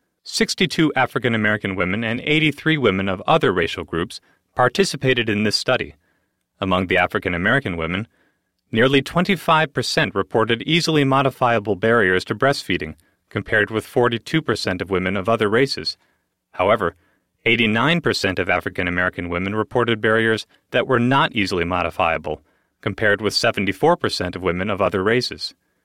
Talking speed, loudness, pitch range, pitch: 130 wpm, -19 LUFS, 95-135 Hz, 115 Hz